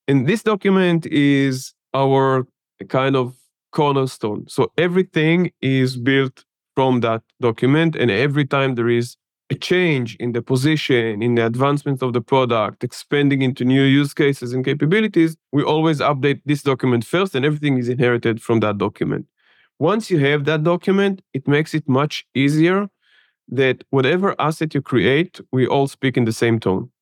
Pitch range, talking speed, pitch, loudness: 125-155 Hz, 160 wpm, 135 Hz, -18 LUFS